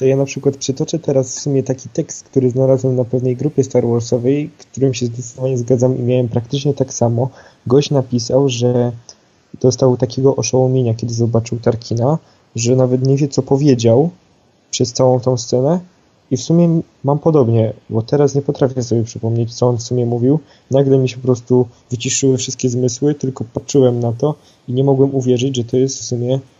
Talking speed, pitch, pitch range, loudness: 185 wpm, 130 Hz, 120-135 Hz, -16 LUFS